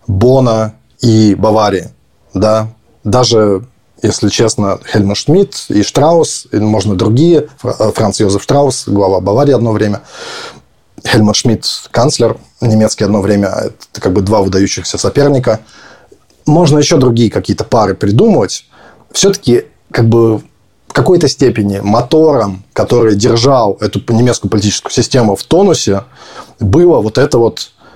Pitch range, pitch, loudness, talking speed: 105-125 Hz, 110 Hz, -10 LUFS, 125 wpm